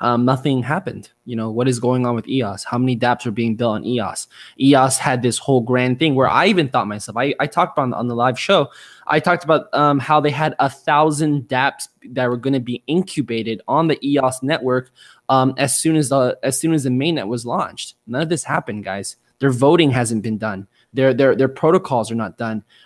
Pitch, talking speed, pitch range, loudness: 130 Hz, 230 wpm, 120-145 Hz, -18 LUFS